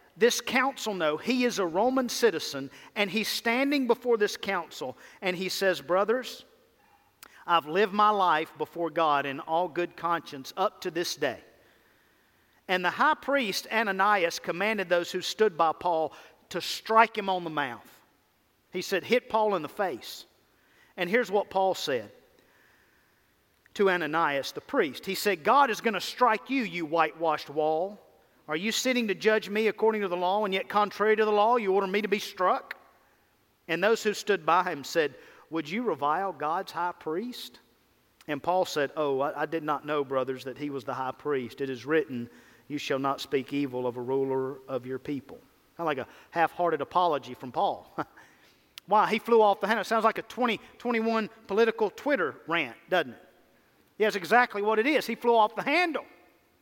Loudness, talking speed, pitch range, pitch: -28 LUFS, 190 wpm, 155-220 Hz, 190 Hz